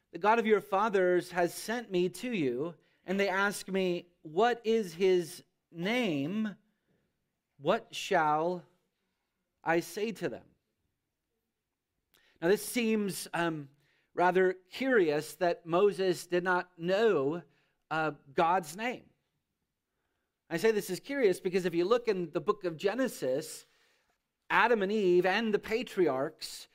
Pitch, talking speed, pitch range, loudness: 185 Hz, 130 wpm, 170-215 Hz, -31 LUFS